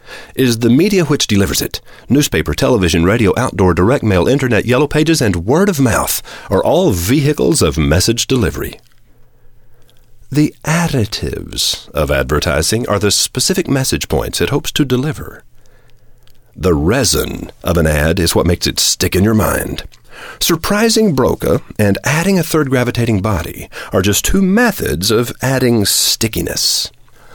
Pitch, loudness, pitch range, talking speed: 120 Hz, -13 LUFS, 95-135 Hz, 145 wpm